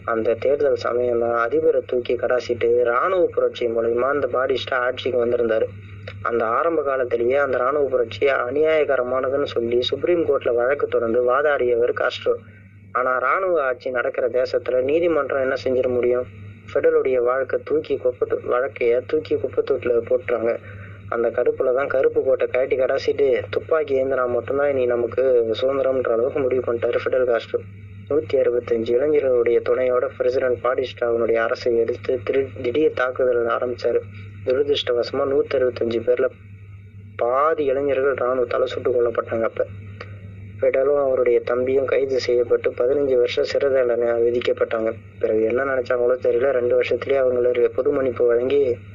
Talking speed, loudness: 125 wpm, -21 LUFS